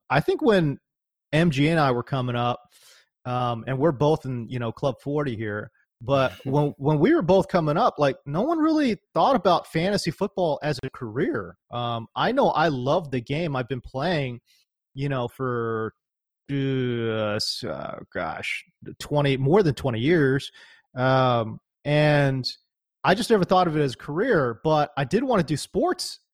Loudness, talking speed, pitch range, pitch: -24 LUFS, 175 wpm, 125-170 Hz, 140 Hz